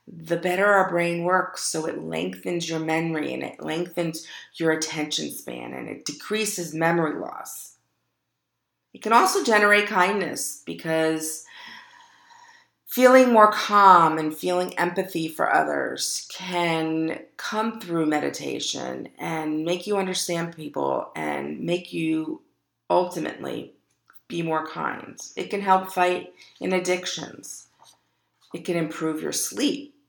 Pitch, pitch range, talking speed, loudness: 175 Hz, 160-205 Hz, 125 wpm, -23 LUFS